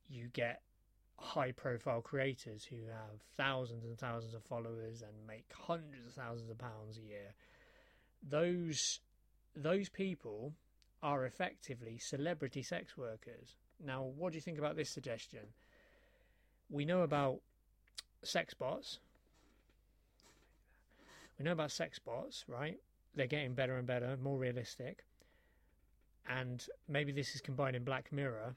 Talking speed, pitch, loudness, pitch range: 130 wpm, 130 Hz, -42 LUFS, 115-145 Hz